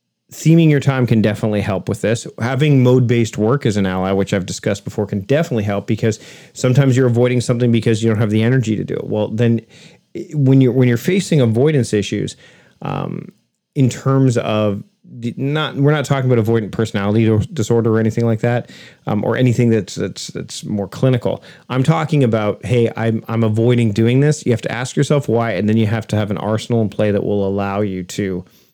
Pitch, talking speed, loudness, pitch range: 115 Hz, 205 wpm, -16 LUFS, 105-130 Hz